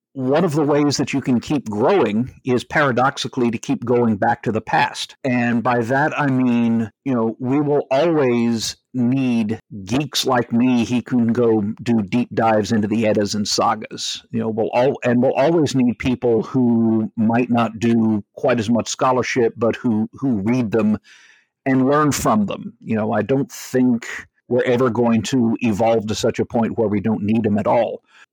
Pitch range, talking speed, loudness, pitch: 110-130 Hz, 190 wpm, -19 LUFS, 120 Hz